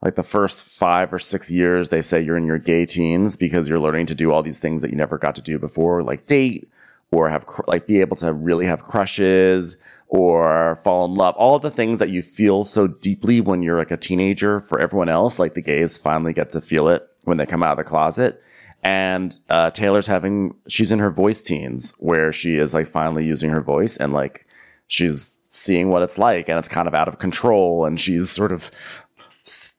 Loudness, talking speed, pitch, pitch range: -19 LUFS, 230 wpm, 90 Hz, 80-100 Hz